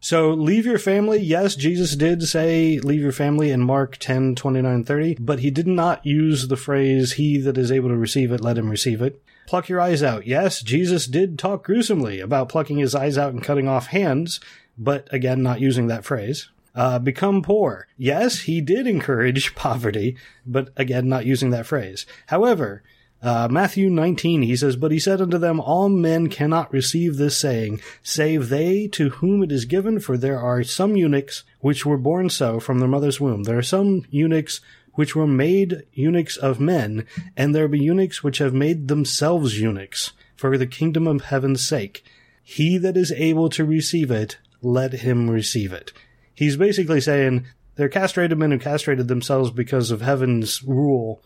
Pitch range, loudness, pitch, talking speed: 130-165 Hz, -20 LUFS, 145 Hz, 185 wpm